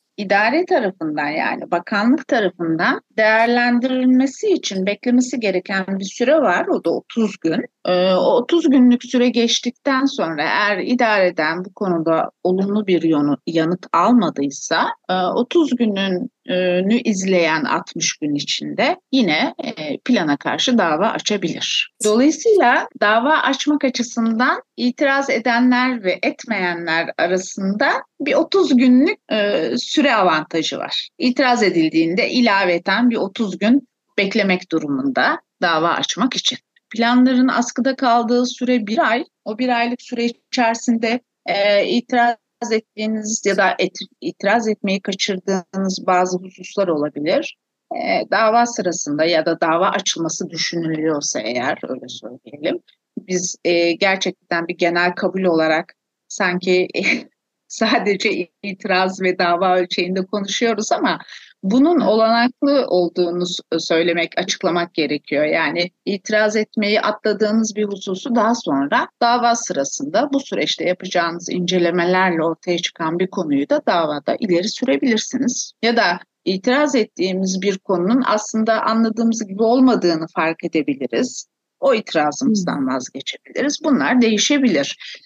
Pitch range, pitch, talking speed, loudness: 180-250 Hz, 215 Hz, 115 wpm, -18 LUFS